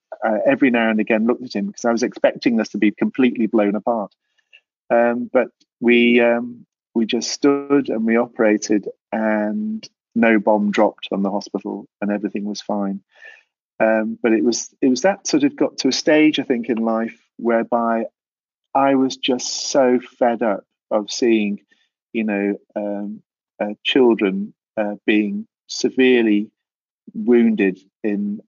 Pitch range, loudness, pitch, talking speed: 105-120 Hz, -19 LUFS, 110 Hz, 160 wpm